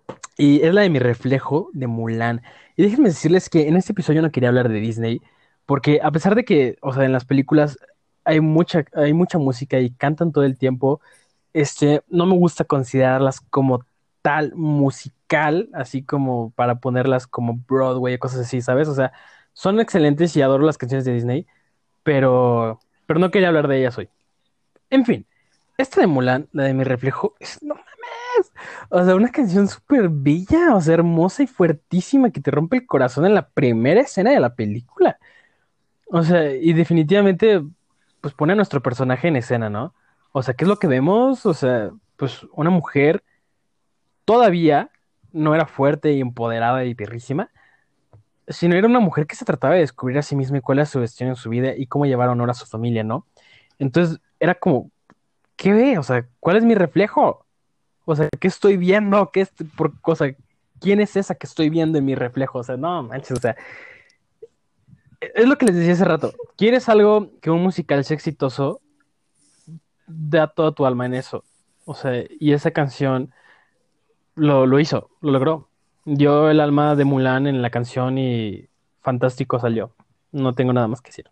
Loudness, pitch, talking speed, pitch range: -19 LUFS, 145 Hz, 185 wpm, 130-175 Hz